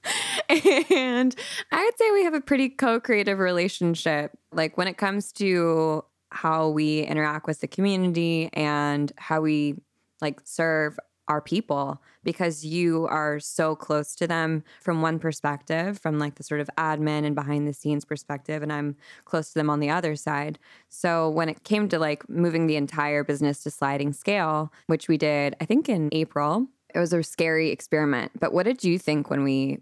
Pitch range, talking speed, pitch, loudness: 150-175 Hz, 185 wpm, 160 Hz, -25 LUFS